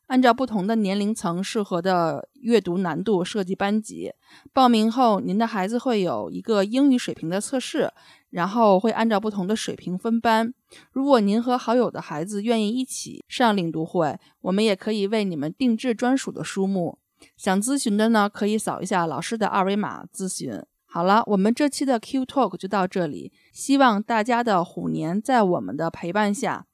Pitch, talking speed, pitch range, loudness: 210 Hz, 290 characters per minute, 185-235 Hz, -23 LUFS